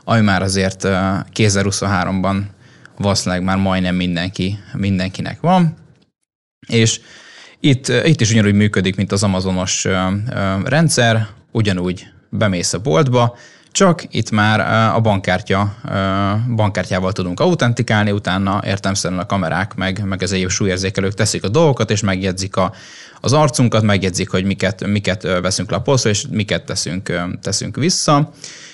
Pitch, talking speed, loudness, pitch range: 100 Hz, 125 wpm, -17 LUFS, 95-115 Hz